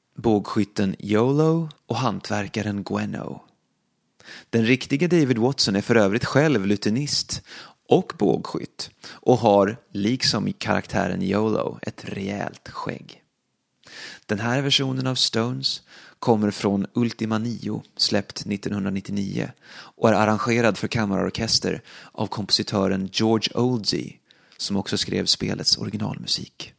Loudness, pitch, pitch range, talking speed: -23 LUFS, 110 Hz, 100-125 Hz, 110 wpm